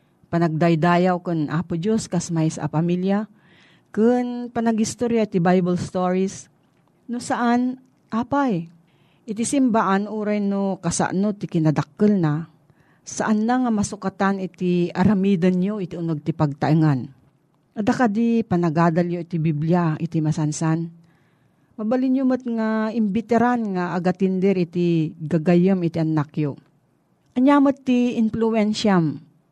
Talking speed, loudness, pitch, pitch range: 120 wpm, -21 LUFS, 180 Hz, 165-220 Hz